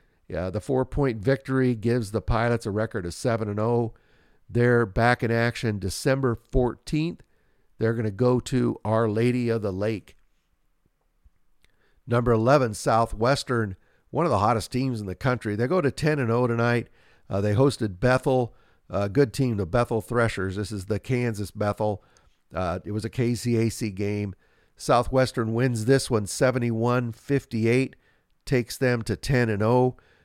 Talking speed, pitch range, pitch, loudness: 160 wpm, 110-125 Hz, 115 Hz, -25 LUFS